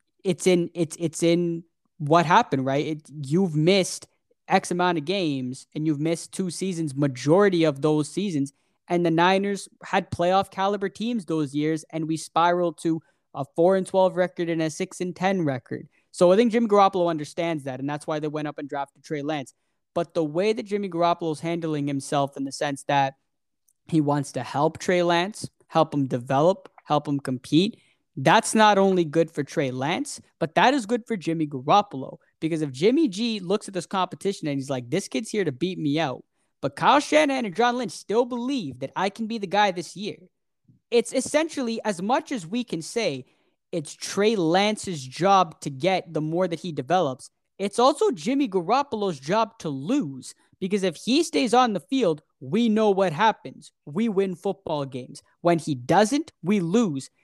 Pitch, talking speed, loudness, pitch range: 175 Hz, 195 wpm, -24 LUFS, 150-205 Hz